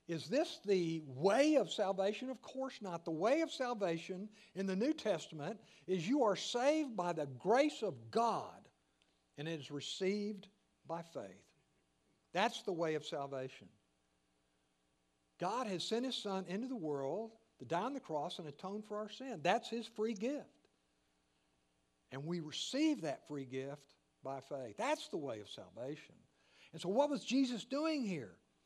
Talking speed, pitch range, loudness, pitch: 165 wpm, 140-235 Hz, -39 LUFS, 185 Hz